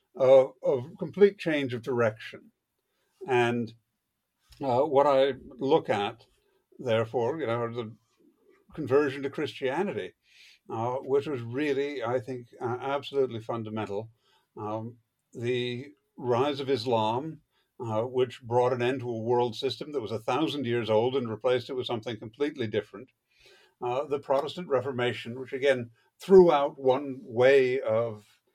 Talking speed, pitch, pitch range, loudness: 140 wpm, 130 Hz, 120-140 Hz, -28 LUFS